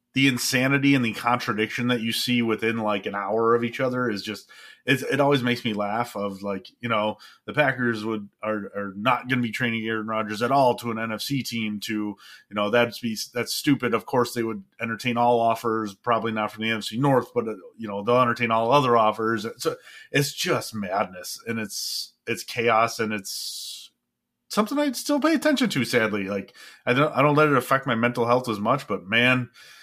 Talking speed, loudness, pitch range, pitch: 215 wpm, -24 LUFS, 110-125 Hz, 115 Hz